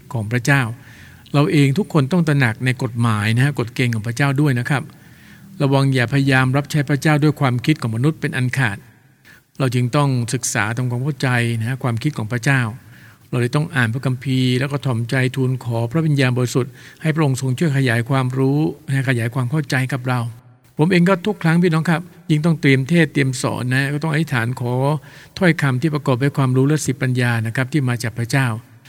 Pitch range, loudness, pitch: 125-145 Hz, -18 LUFS, 135 Hz